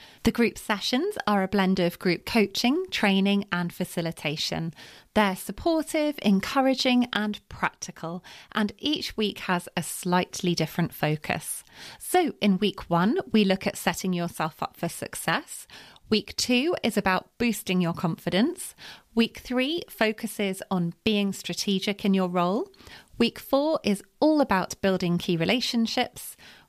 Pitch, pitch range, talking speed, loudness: 200 Hz, 180-235 Hz, 135 wpm, -26 LUFS